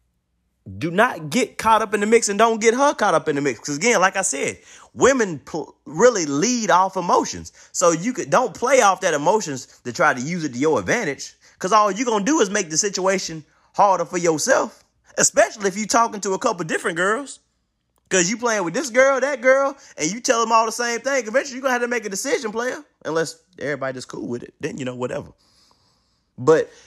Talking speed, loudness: 230 wpm, -20 LUFS